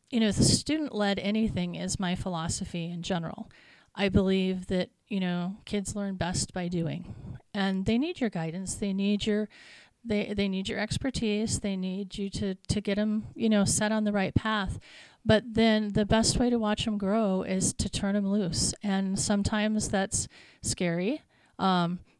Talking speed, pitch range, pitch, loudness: 185 wpm, 190-215 Hz, 200 Hz, -29 LUFS